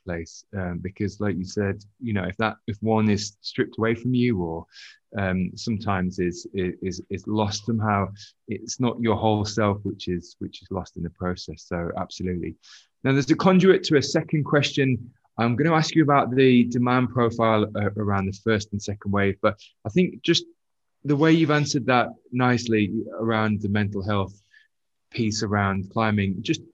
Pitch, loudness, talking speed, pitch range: 110 Hz, -24 LUFS, 180 wpm, 100-125 Hz